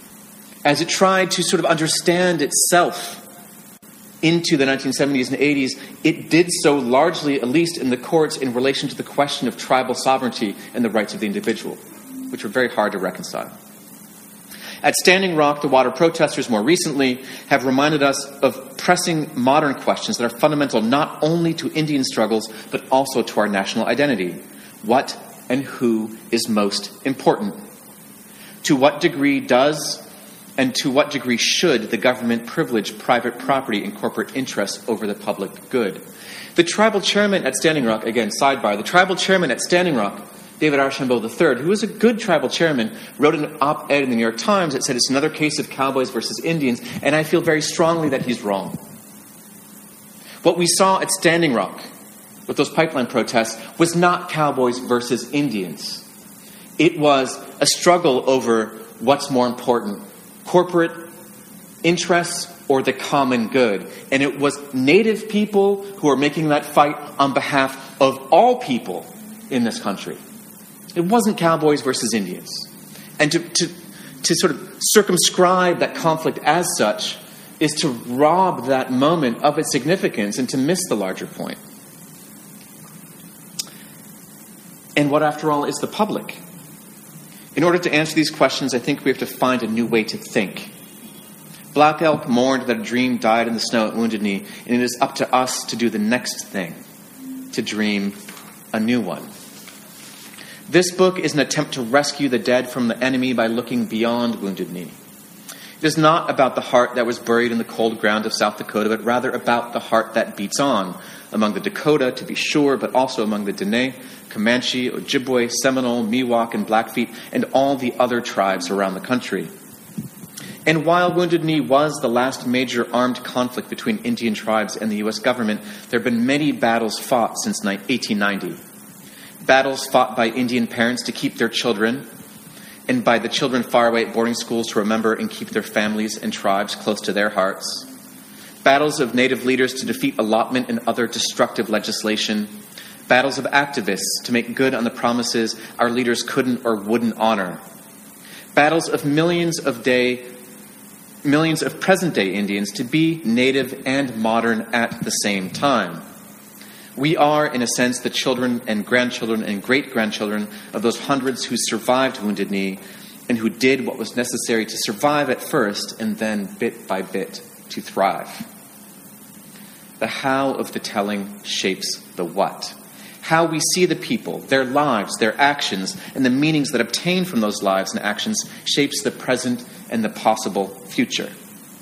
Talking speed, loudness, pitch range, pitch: 170 wpm, -19 LUFS, 120-165 Hz, 135 Hz